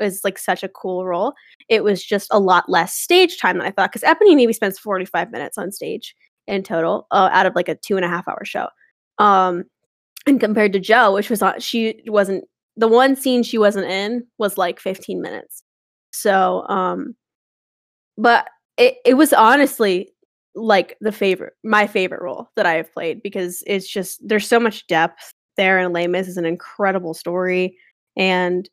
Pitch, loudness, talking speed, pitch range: 200 Hz, -18 LUFS, 190 wpm, 185-225 Hz